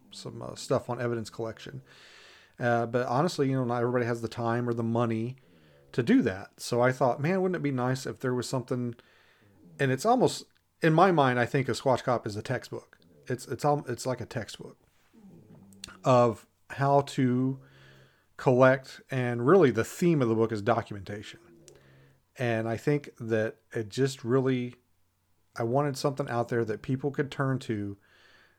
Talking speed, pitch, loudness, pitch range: 180 wpm, 120 Hz, -28 LUFS, 115-135 Hz